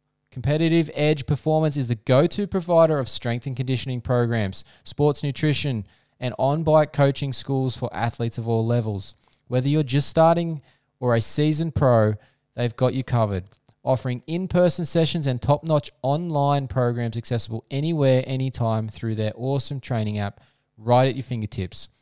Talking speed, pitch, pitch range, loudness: 160 wpm, 130 Hz, 120-150 Hz, -23 LUFS